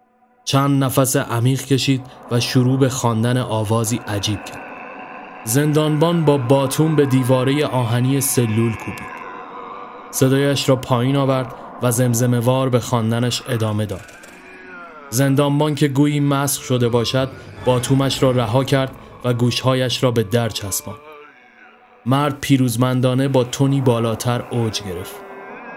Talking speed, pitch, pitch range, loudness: 125 wpm, 130 Hz, 120-140 Hz, -18 LUFS